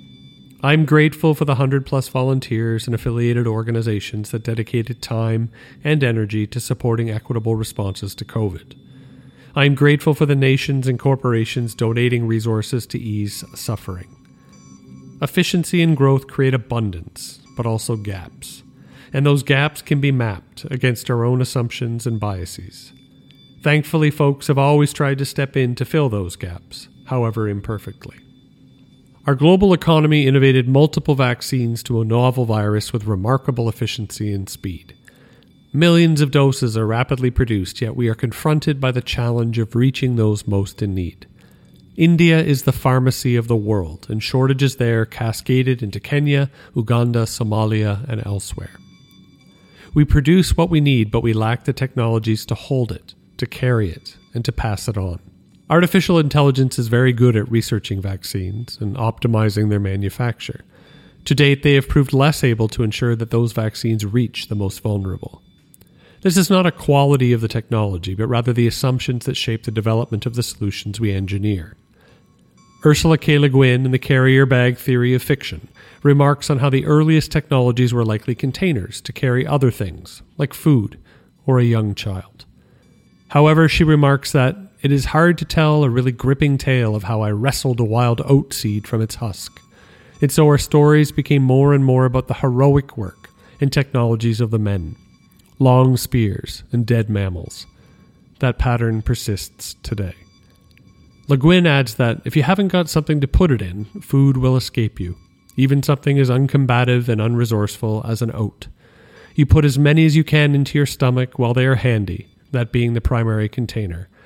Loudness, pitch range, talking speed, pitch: -18 LUFS, 110-140 Hz, 165 wpm, 125 Hz